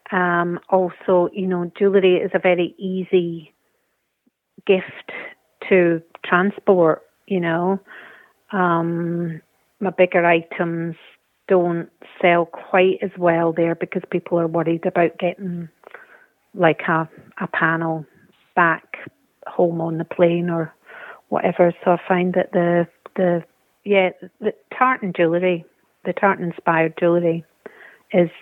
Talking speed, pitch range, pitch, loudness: 120 wpm, 170-185 Hz, 175 Hz, -20 LUFS